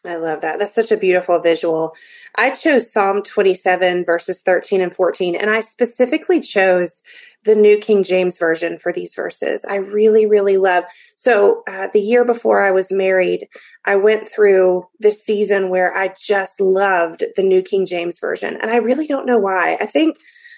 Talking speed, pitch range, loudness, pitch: 180 wpm, 185-230 Hz, -16 LUFS, 195 Hz